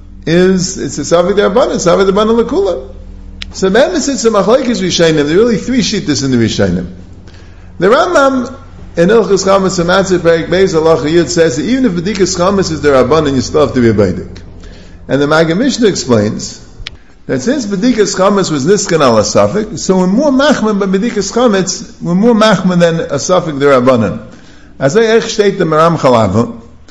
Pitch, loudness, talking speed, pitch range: 175 Hz, -10 LUFS, 180 wpm, 135-210 Hz